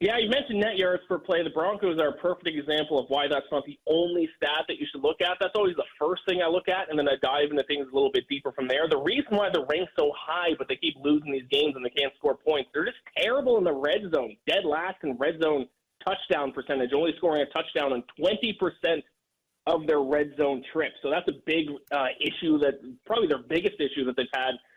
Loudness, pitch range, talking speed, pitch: -27 LUFS, 145-210 Hz, 245 wpm, 160 Hz